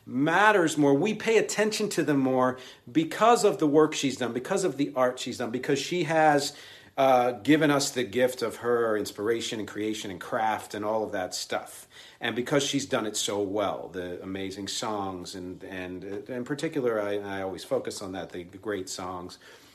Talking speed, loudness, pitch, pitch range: 195 wpm, -27 LUFS, 125 Hz, 100-150 Hz